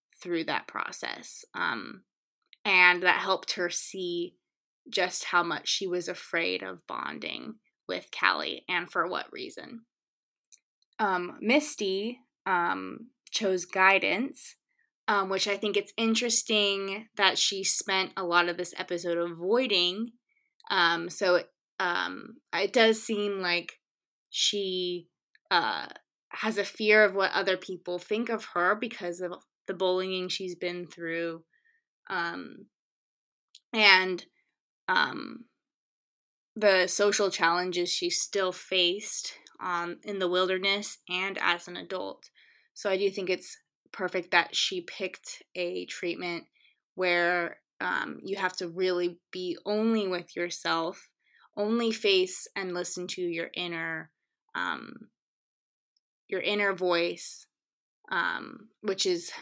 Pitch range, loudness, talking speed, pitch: 175-220 Hz, -28 LUFS, 125 wpm, 190 Hz